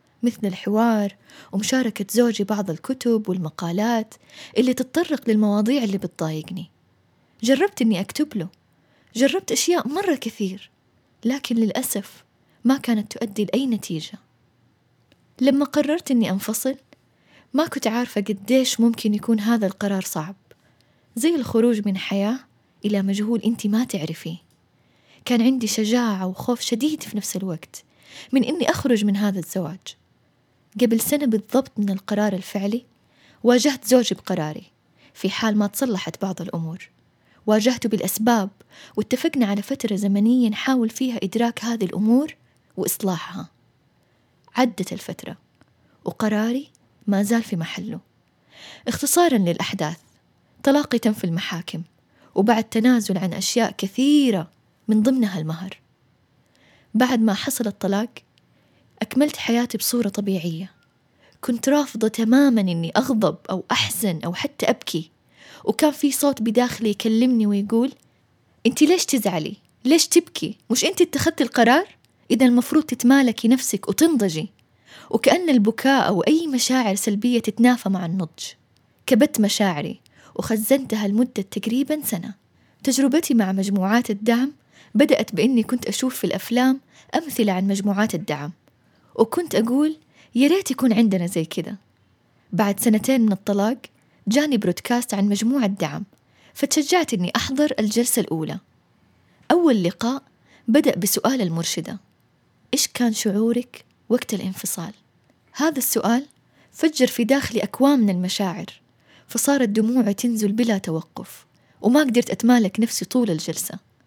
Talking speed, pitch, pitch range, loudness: 120 wpm, 225 Hz, 195-255 Hz, -21 LUFS